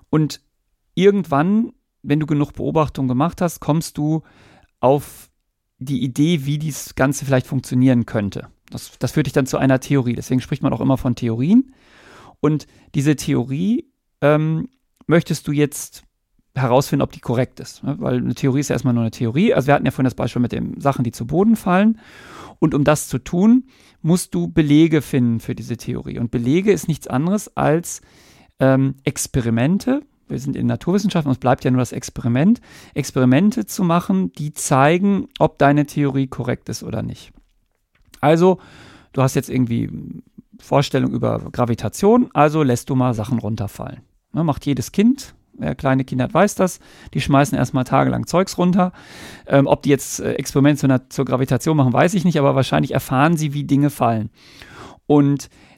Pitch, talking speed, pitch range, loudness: 140 Hz, 170 wpm, 130-165 Hz, -19 LUFS